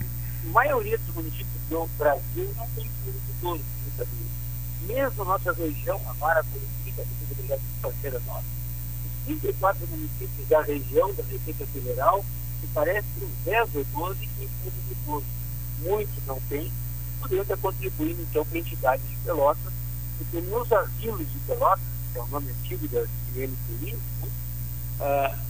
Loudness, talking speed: -28 LUFS, 160 wpm